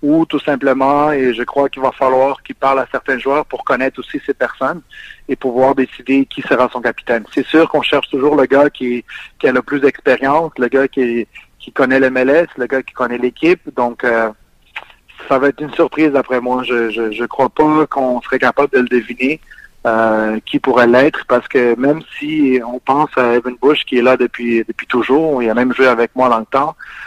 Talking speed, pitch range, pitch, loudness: 215 wpm, 125-145 Hz, 130 Hz, -14 LUFS